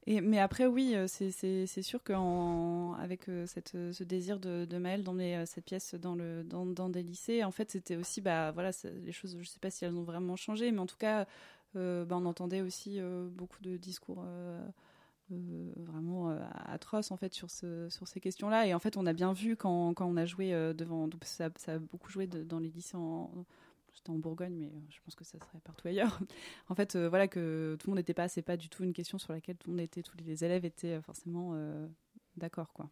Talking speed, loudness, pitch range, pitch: 240 wpm, -37 LUFS, 170-190 Hz, 180 Hz